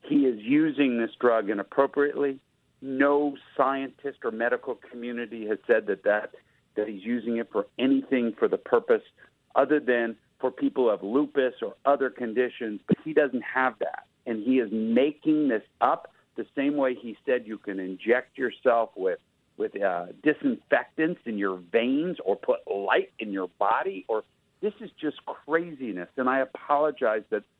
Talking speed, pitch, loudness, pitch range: 165 wpm, 135 Hz, -27 LUFS, 120-150 Hz